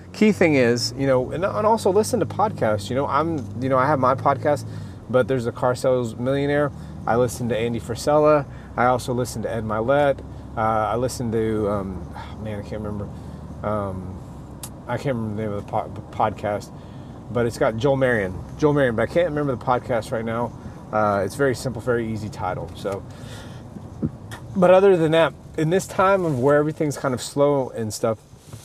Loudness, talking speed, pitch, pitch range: -22 LUFS, 195 wpm, 125 Hz, 110-140 Hz